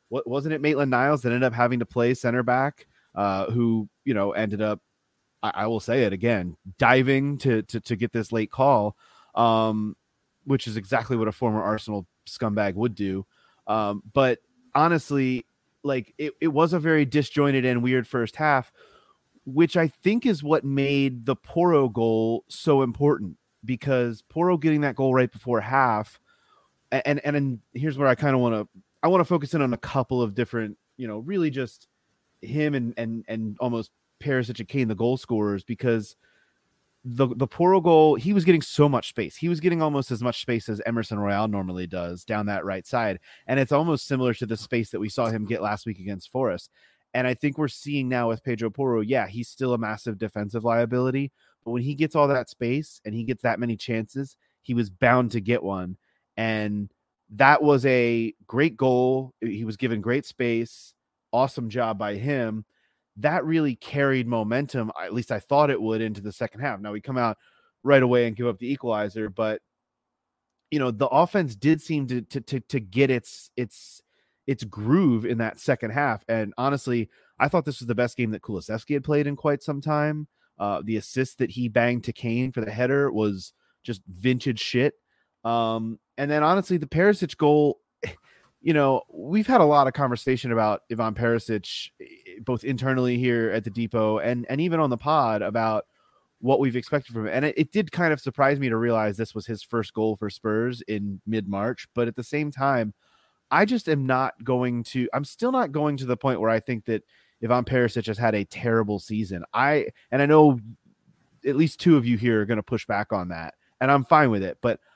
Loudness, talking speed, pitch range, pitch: -24 LUFS, 205 wpm, 110-140 Hz, 125 Hz